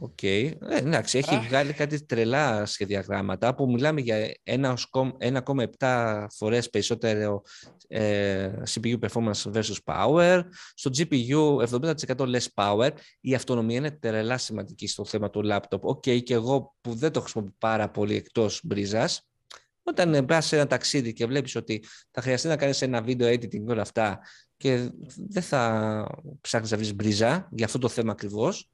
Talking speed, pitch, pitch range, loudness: 150 wpm, 120 Hz, 110-135 Hz, -26 LUFS